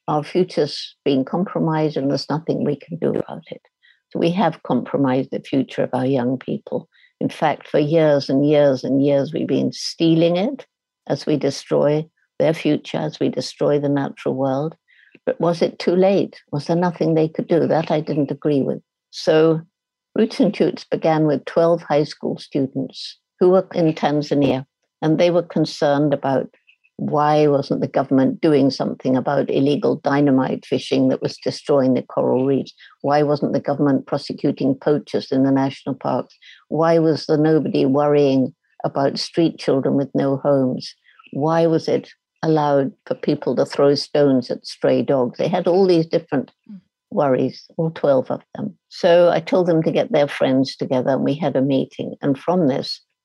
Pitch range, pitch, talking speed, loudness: 140-165 Hz, 150 Hz, 175 wpm, -19 LUFS